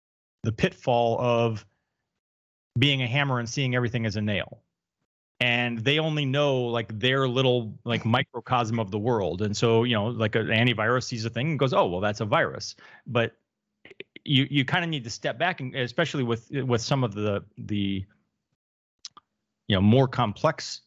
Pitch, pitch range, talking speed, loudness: 120 Hz, 110-135 Hz, 180 wpm, -25 LUFS